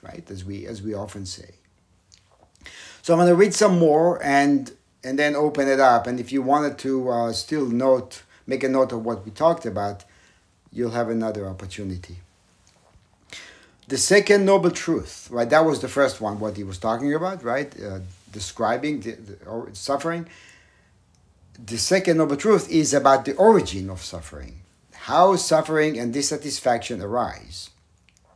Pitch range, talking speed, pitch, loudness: 95-145 Hz, 160 wpm, 120 Hz, -21 LUFS